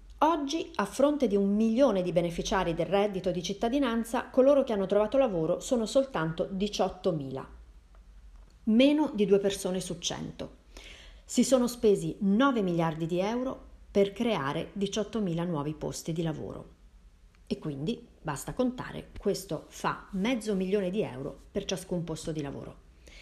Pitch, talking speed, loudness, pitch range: 195 Hz, 140 wpm, -29 LUFS, 165-230 Hz